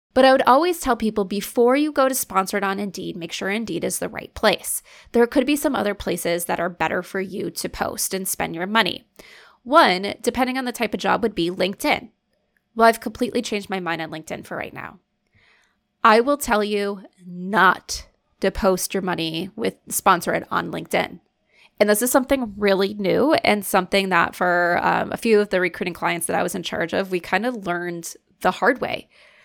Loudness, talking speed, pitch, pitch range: -21 LUFS, 205 wpm, 205 Hz, 185-240 Hz